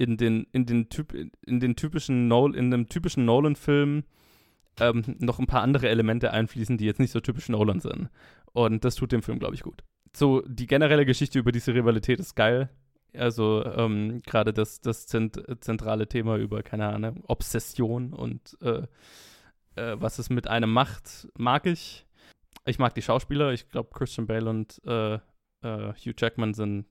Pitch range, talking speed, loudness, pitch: 110-130 Hz, 175 wpm, -27 LUFS, 120 Hz